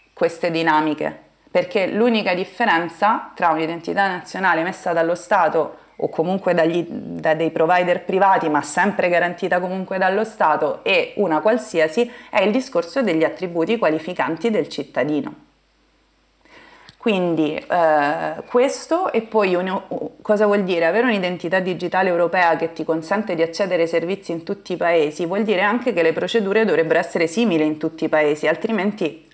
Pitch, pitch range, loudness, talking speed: 185 Hz, 165-220 Hz, -19 LUFS, 150 wpm